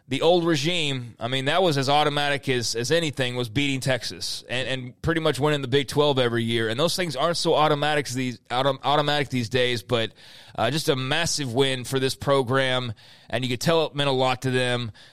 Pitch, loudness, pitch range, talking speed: 135 Hz, -23 LUFS, 125-150 Hz, 210 wpm